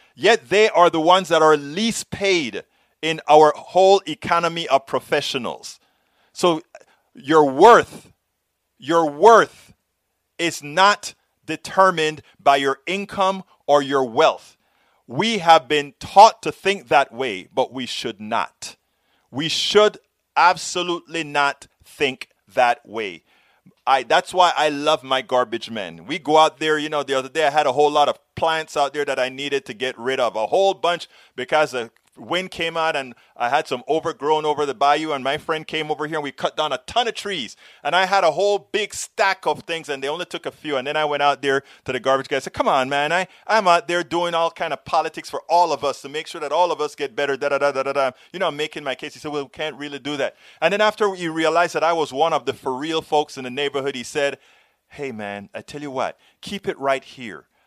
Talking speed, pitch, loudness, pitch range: 215 wpm, 155 Hz, -20 LUFS, 140-175 Hz